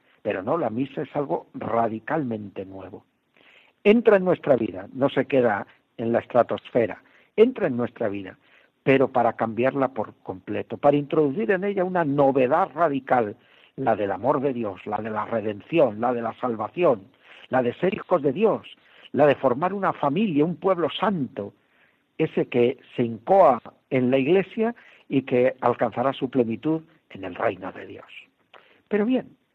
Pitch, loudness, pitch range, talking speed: 135 Hz, -23 LUFS, 120-170 Hz, 160 wpm